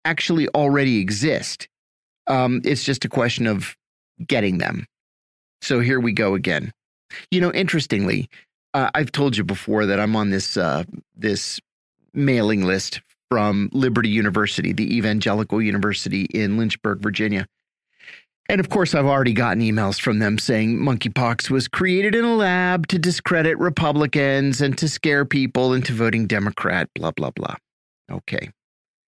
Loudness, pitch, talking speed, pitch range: -20 LUFS, 125 Hz, 145 wpm, 105-150 Hz